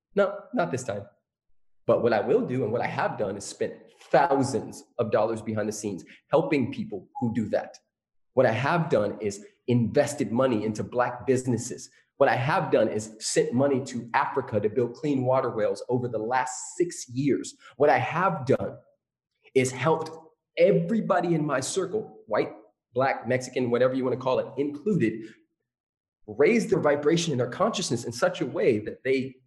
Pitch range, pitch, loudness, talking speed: 120-175 Hz, 135 Hz, -26 LUFS, 180 wpm